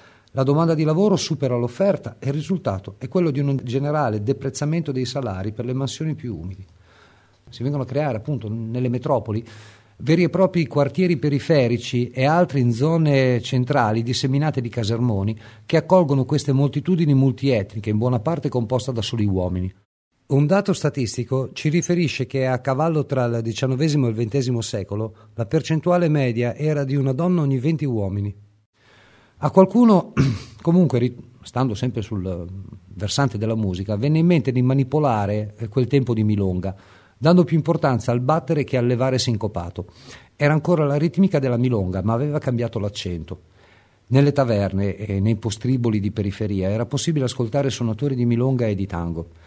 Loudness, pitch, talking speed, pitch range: -21 LUFS, 125 Hz, 160 wpm, 110-145 Hz